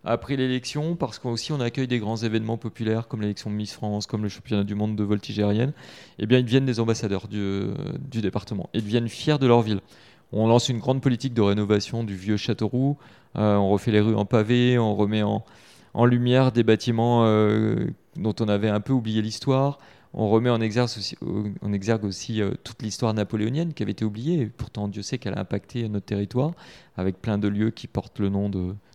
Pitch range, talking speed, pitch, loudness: 105-125 Hz, 220 wpm, 110 Hz, -24 LUFS